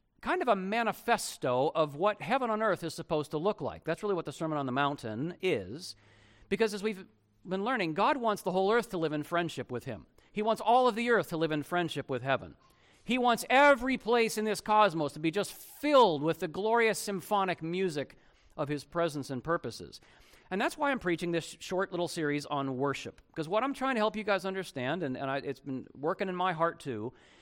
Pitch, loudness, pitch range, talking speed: 175 Hz, -31 LUFS, 145-215 Hz, 225 wpm